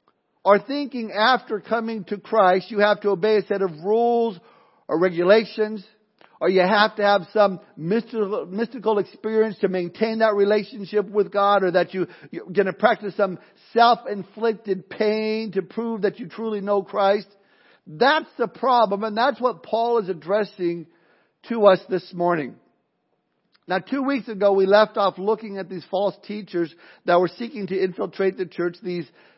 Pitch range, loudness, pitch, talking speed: 190-220 Hz, -22 LUFS, 205 Hz, 165 wpm